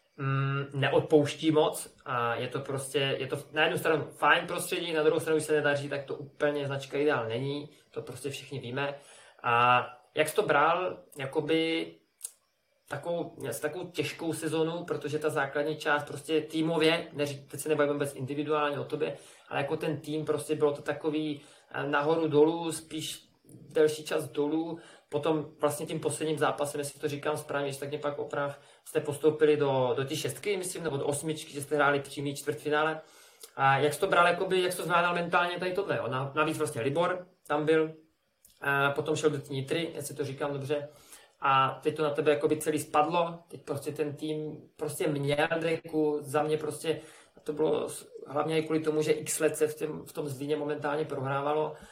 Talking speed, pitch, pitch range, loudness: 185 wpm, 150 Hz, 145-155 Hz, -30 LUFS